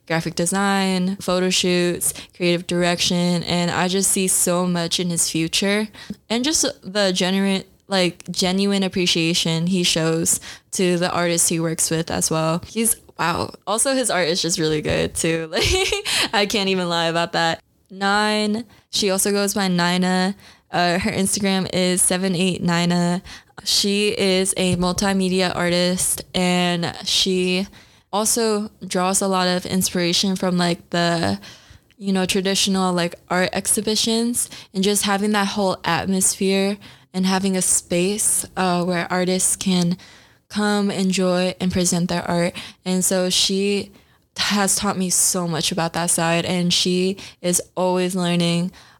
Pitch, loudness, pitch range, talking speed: 185 Hz, -19 LUFS, 175-195 Hz, 145 wpm